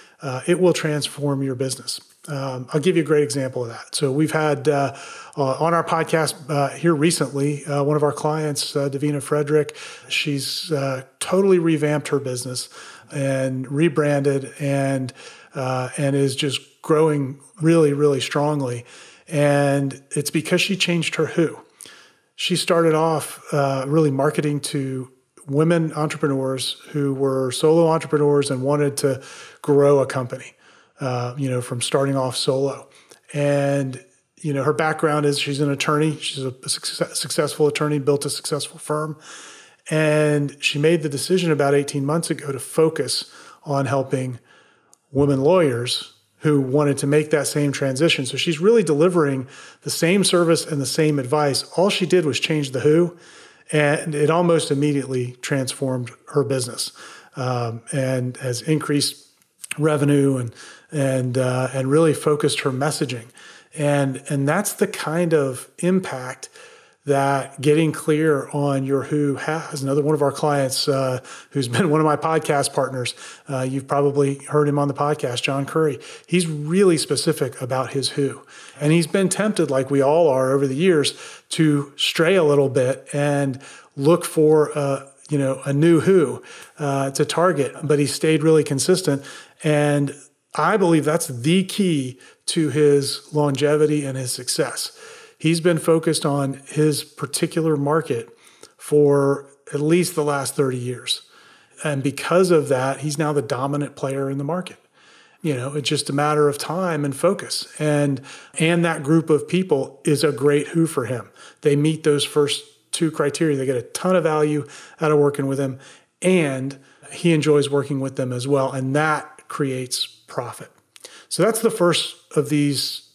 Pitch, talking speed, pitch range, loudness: 145 Hz, 160 wpm, 140-160 Hz, -21 LUFS